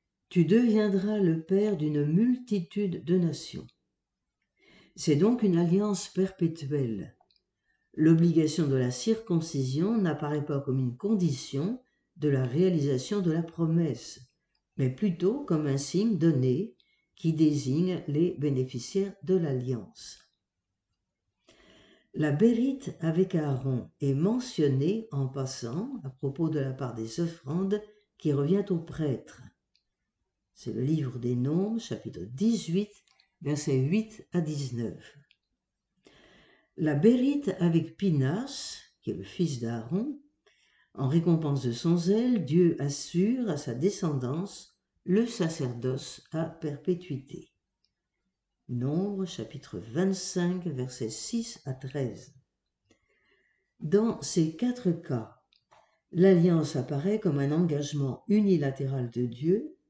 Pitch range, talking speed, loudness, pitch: 140-195 Hz, 110 wpm, -29 LUFS, 165 Hz